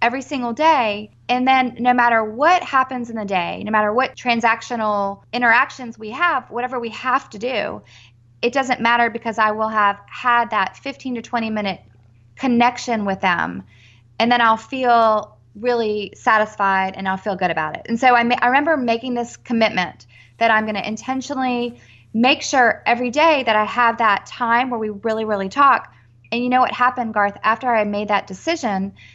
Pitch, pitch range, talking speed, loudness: 230 Hz, 205-250 Hz, 185 wpm, -19 LUFS